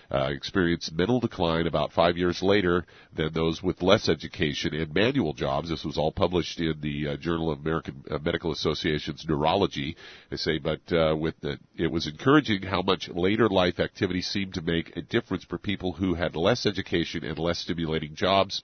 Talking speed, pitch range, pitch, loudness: 190 wpm, 80-95 Hz, 85 Hz, -27 LUFS